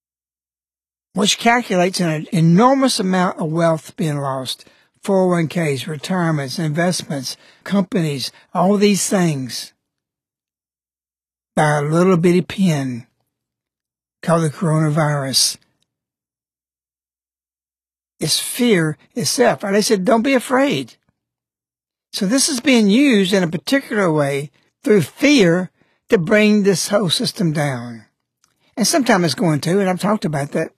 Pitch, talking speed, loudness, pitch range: 170 Hz, 115 wpm, -17 LUFS, 135-200 Hz